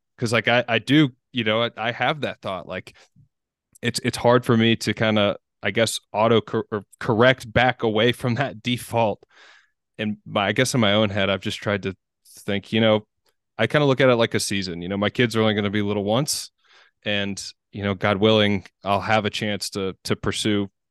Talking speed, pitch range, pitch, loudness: 225 wpm, 100-120 Hz, 110 Hz, -22 LUFS